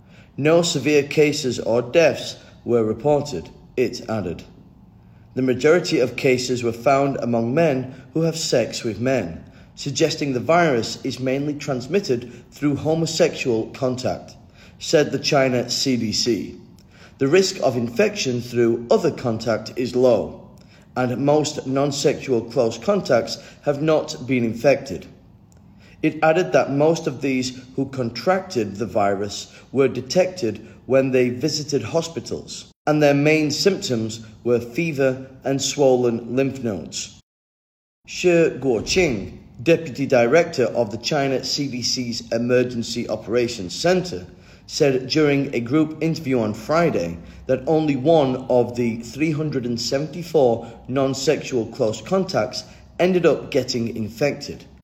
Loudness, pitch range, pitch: -21 LUFS, 115-150 Hz, 130 Hz